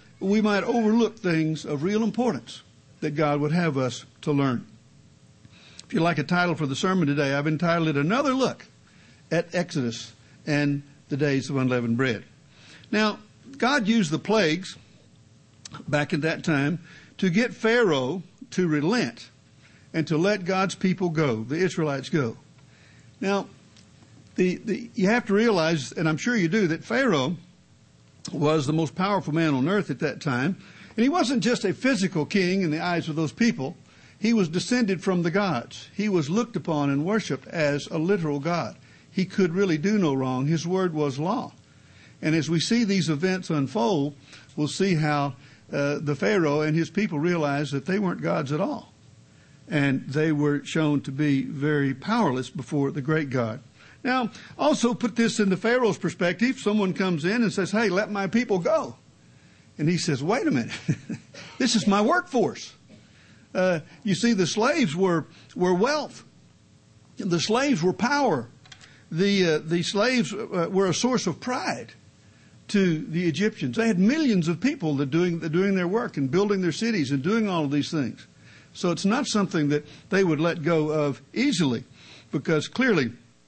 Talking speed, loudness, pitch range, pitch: 175 wpm, -25 LUFS, 150-205 Hz, 170 Hz